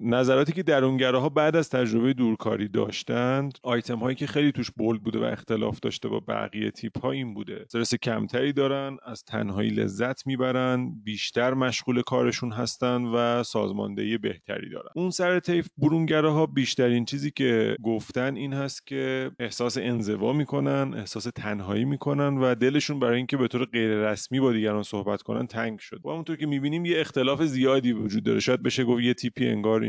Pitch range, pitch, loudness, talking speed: 115-140 Hz, 125 Hz, -26 LUFS, 170 wpm